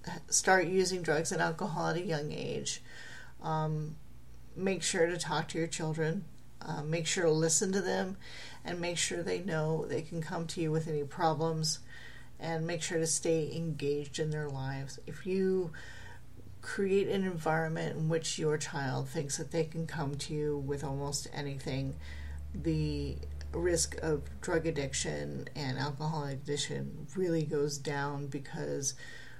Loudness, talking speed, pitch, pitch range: -34 LUFS, 155 wpm, 155 Hz, 140-165 Hz